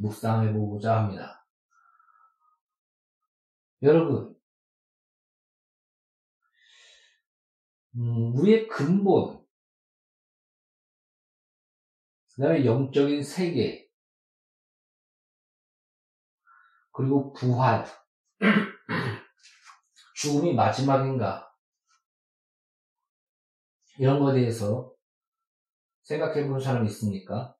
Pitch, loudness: 145 Hz, -25 LUFS